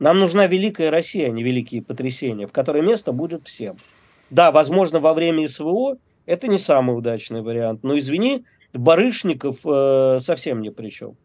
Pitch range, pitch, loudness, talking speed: 125-170 Hz, 145 Hz, -19 LUFS, 165 wpm